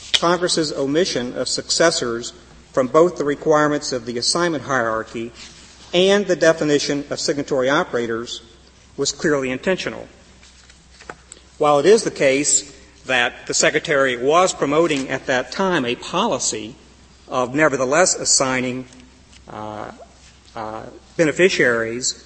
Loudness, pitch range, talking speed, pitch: -18 LUFS, 110-155 Hz, 115 wpm, 130 Hz